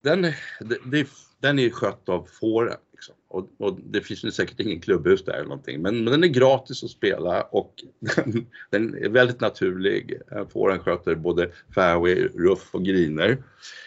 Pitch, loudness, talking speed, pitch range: 125 Hz, -23 LUFS, 165 wpm, 110-150 Hz